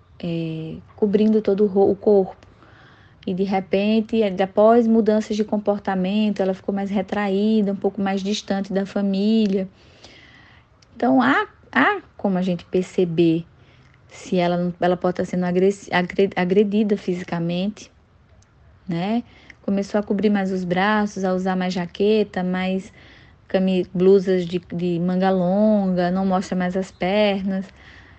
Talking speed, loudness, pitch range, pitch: 130 wpm, -21 LUFS, 180-210 Hz, 195 Hz